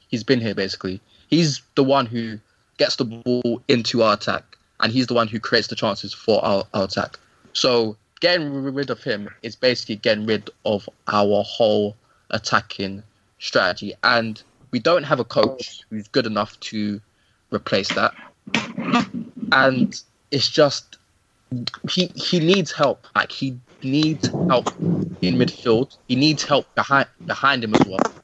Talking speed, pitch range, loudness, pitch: 155 wpm, 105-140 Hz, -21 LUFS, 120 Hz